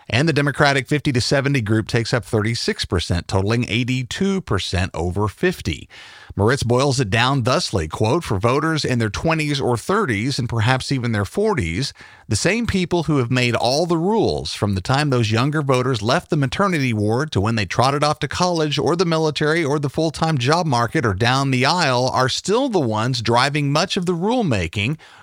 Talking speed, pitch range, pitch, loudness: 190 wpm, 115-155 Hz, 130 Hz, -19 LUFS